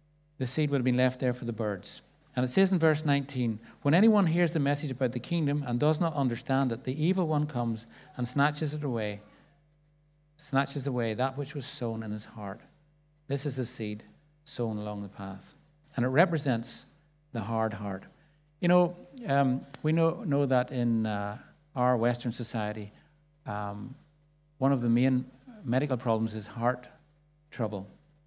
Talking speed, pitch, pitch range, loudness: 175 wpm, 135 Hz, 115-150 Hz, -30 LUFS